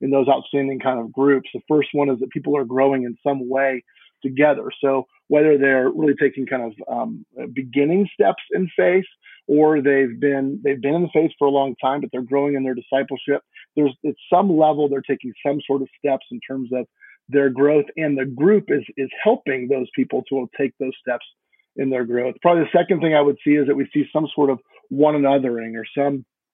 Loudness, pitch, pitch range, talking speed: -20 LUFS, 140 Hz, 135-150 Hz, 215 wpm